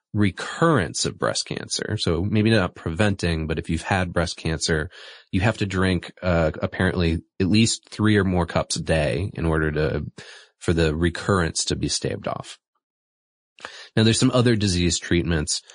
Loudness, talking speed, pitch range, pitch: -22 LUFS, 170 wpm, 80-105 Hz, 90 Hz